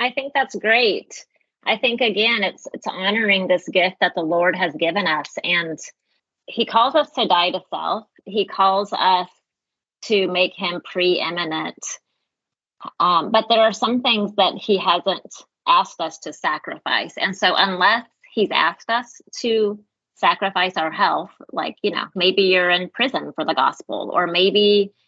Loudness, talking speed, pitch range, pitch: -19 LUFS, 165 wpm, 180-225 Hz, 195 Hz